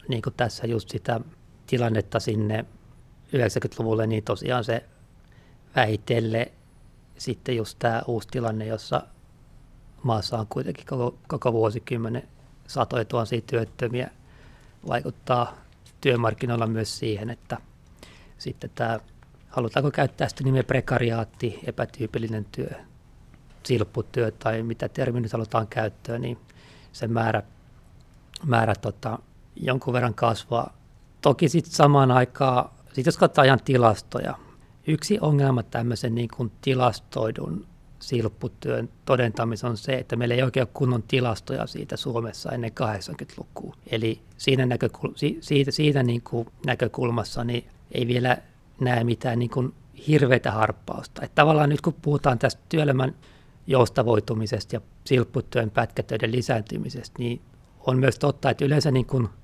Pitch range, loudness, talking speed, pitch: 115-135 Hz, -25 LUFS, 120 wpm, 120 Hz